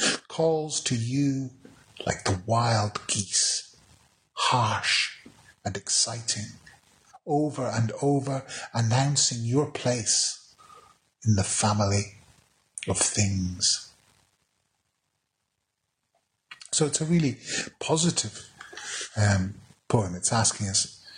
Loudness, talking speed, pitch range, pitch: -26 LUFS, 90 wpm, 105-140 Hz, 120 Hz